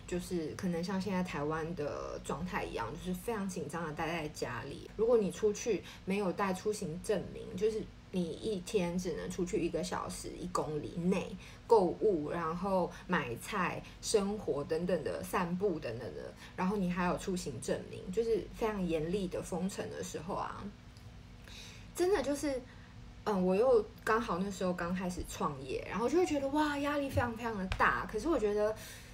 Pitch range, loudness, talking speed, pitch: 170-220 Hz, -35 LUFS, 265 characters per minute, 195 Hz